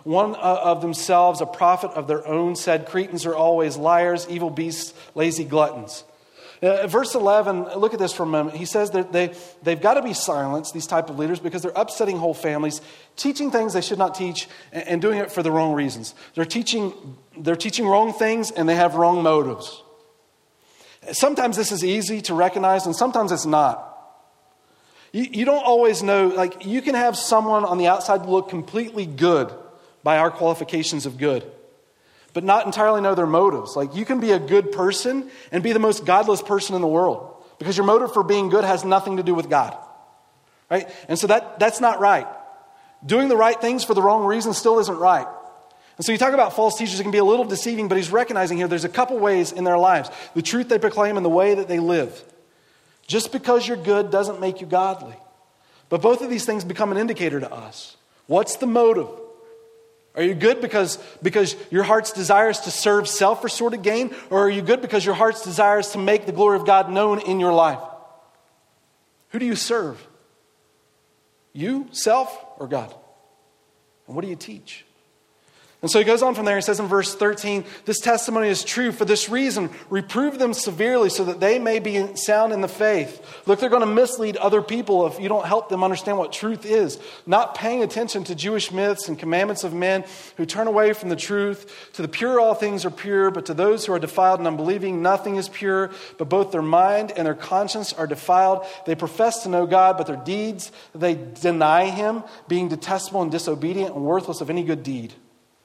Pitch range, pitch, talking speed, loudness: 175-220 Hz, 195 Hz, 210 wpm, -21 LUFS